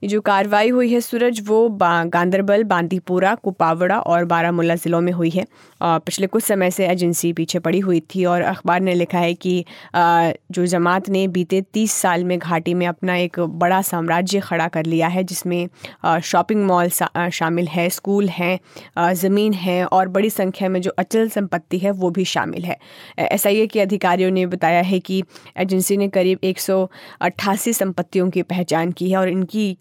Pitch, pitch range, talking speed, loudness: 180 Hz, 175-195 Hz, 175 wpm, -19 LUFS